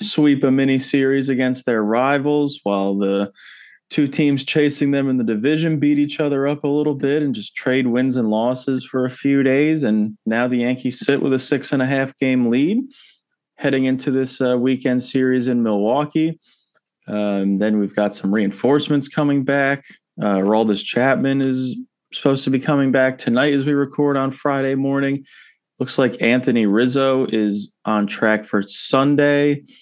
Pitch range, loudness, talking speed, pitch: 120-145 Hz, -18 LUFS, 175 wpm, 135 Hz